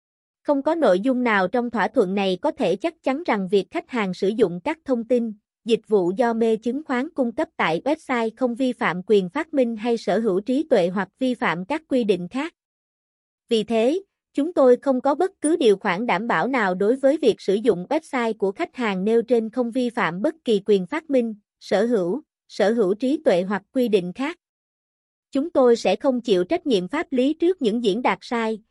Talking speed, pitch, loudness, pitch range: 220 wpm, 240 Hz, -22 LUFS, 210-275 Hz